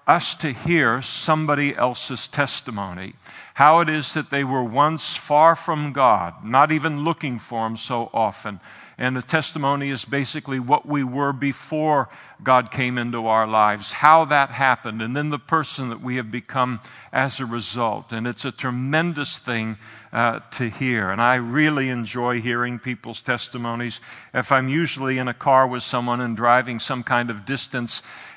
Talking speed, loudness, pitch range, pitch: 170 wpm, -21 LUFS, 120-145 Hz, 130 Hz